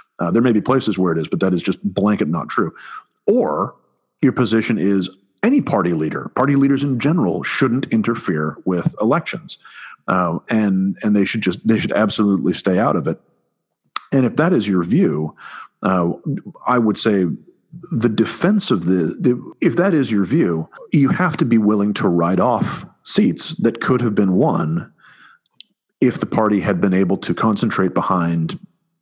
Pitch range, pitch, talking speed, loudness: 95-130 Hz, 105 Hz, 180 wpm, -18 LUFS